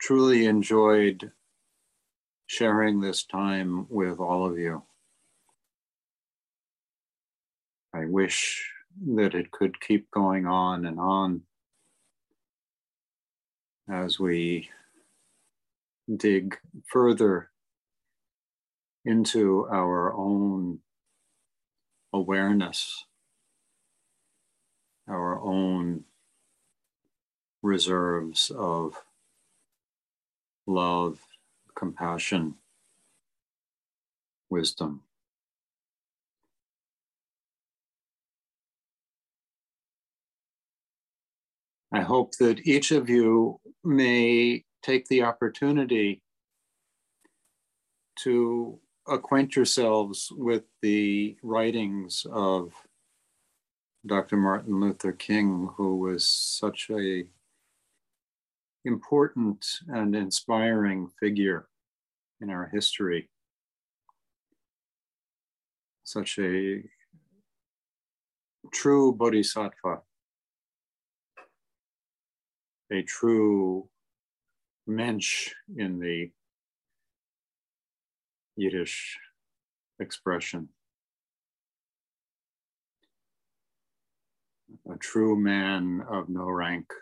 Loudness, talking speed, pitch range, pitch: -26 LUFS, 55 wpm, 90-115 Hz, 100 Hz